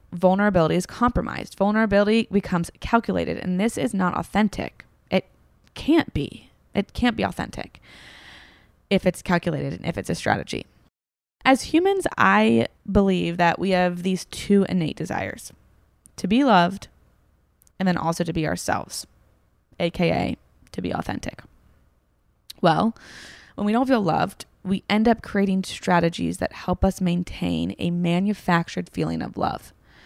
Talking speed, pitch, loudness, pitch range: 140 wpm, 185 Hz, -23 LUFS, 170-205 Hz